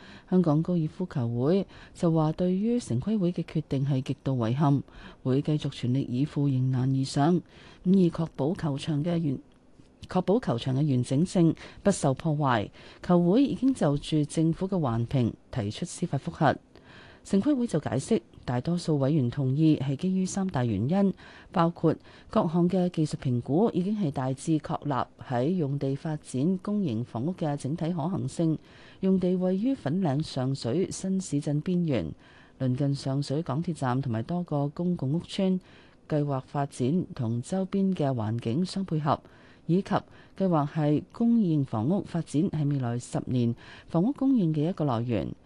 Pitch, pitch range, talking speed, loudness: 155 Hz, 135-180 Hz, 245 characters per minute, -28 LUFS